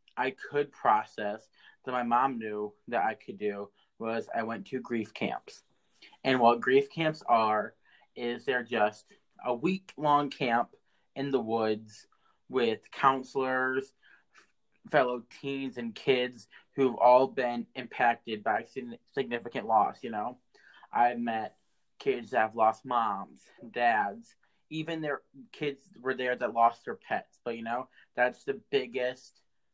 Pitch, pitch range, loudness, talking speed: 125 Hz, 115-135 Hz, -30 LUFS, 140 wpm